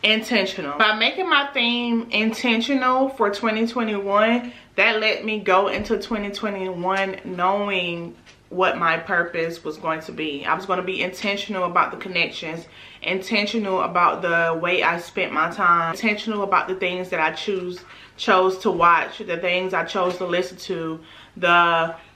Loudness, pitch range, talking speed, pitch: -21 LUFS, 170-215 Hz, 155 wpm, 190 Hz